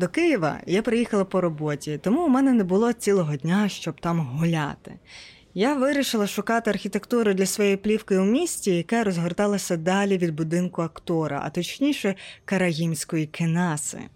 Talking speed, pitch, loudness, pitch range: 150 wpm, 190 Hz, -24 LUFS, 170-215 Hz